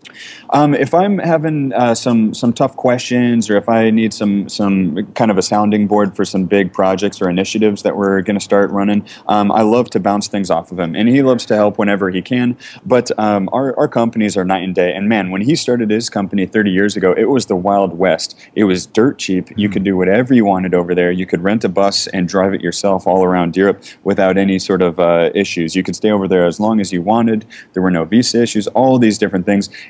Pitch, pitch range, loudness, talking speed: 100 Hz, 95-115 Hz, -14 LUFS, 245 wpm